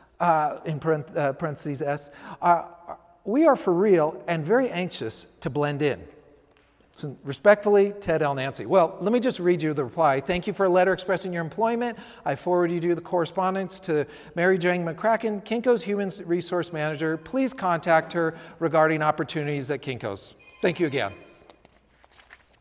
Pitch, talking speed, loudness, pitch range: 170 Hz, 160 wpm, -25 LUFS, 150-190 Hz